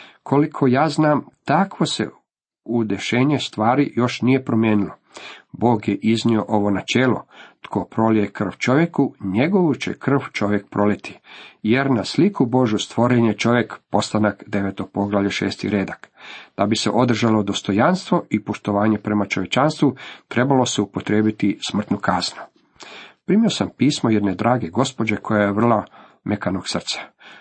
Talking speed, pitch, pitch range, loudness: 135 wpm, 115 Hz, 105-130 Hz, -20 LUFS